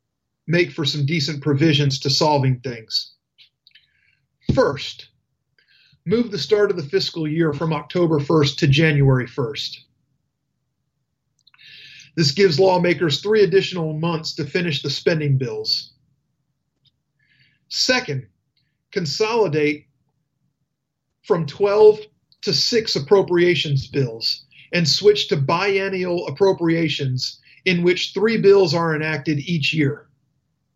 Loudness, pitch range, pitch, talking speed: -19 LUFS, 140-175 Hz, 150 Hz, 105 wpm